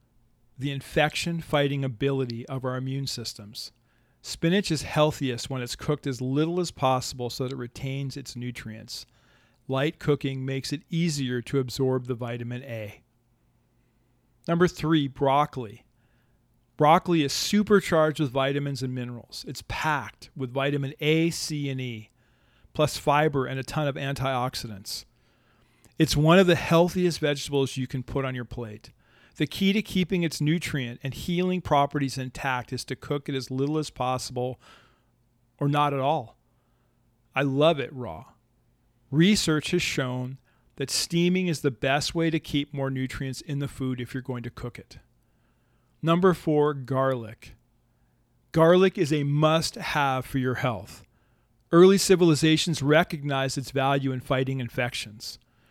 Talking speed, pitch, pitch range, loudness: 150 wpm, 135 Hz, 125-150 Hz, -26 LUFS